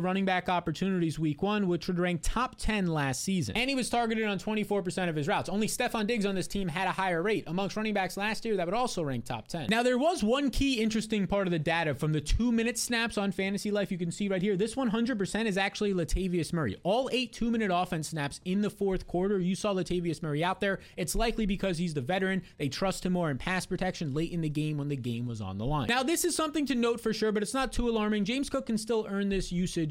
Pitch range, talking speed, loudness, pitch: 175-220 Hz, 265 wpm, -30 LUFS, 195 Hz